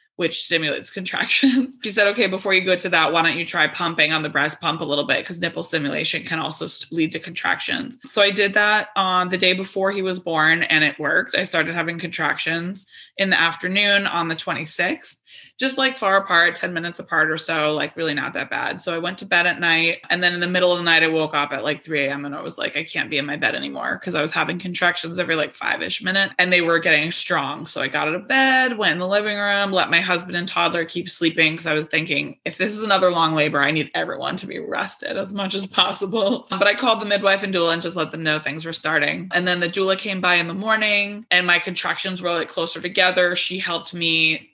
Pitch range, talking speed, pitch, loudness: 165-195 Hz, 255 wpm, 175 Hz, -19 LUFS